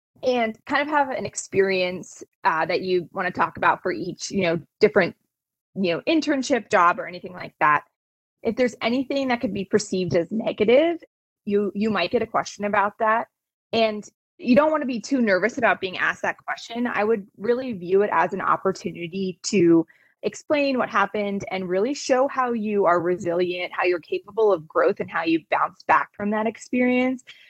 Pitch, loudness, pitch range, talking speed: 210 Hz, -23 LUFS, 185-250 Hz, 190 wpm